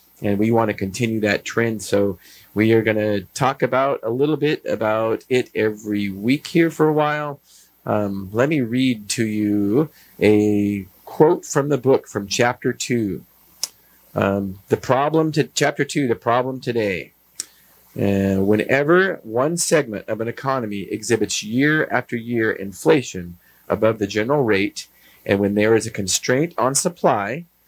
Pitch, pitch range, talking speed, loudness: 110 Hz, 100-135 Hz, 155 wpm, -20 LUFS